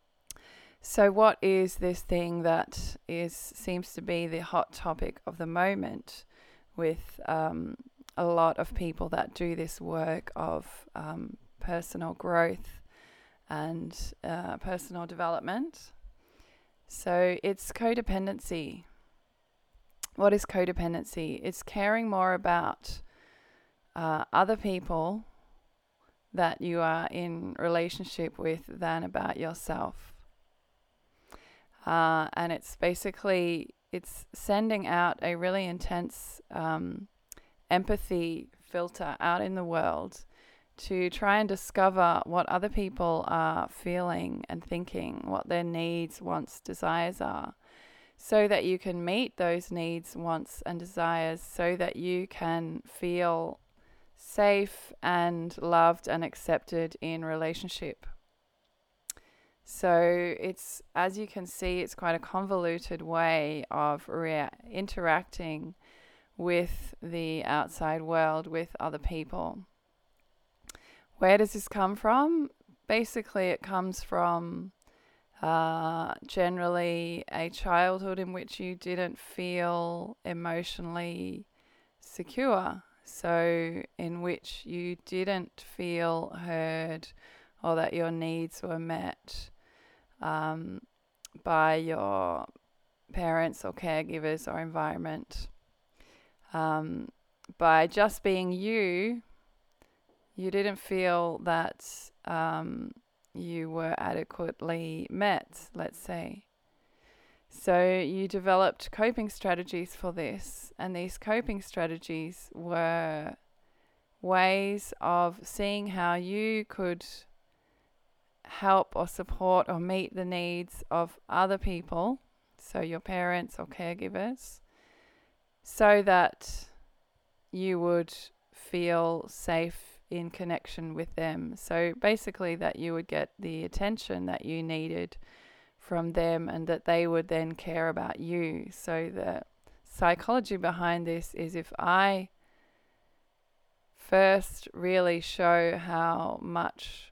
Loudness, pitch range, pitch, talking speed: -31 LUFS, 165-190 Hz, 175 Hz, 110 wpm